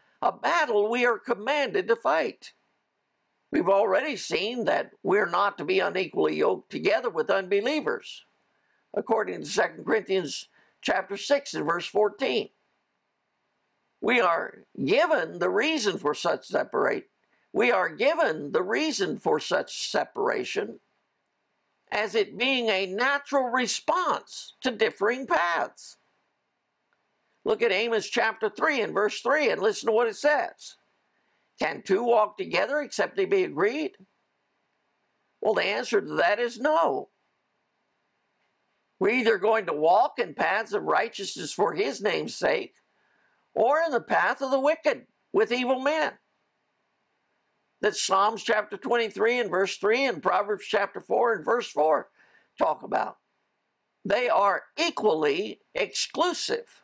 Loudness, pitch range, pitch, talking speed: -26 LUFS, 215-335 Hz, 250 Hz, 135 wpm